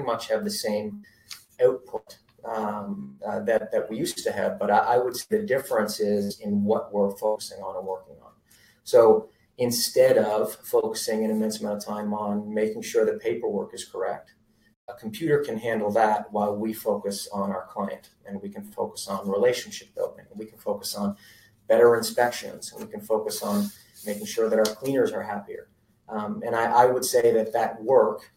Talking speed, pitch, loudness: 190 wpm, 115 Hz, -25 LUFS